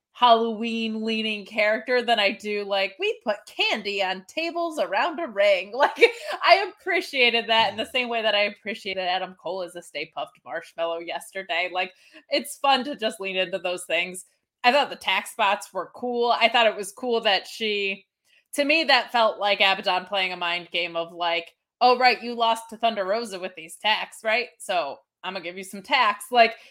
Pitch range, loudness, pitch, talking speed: 190-250 Hz, -23 LUFS, 220 Hz, 200 wpm